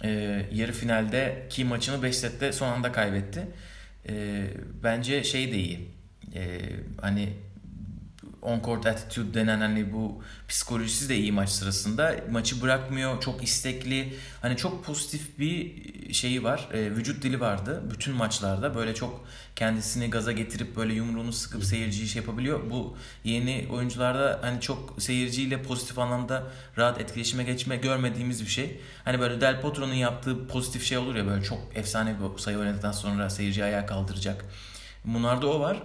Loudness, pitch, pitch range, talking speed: -29 LUFS, 115 Hz, 105-130 Hz, 150 wpm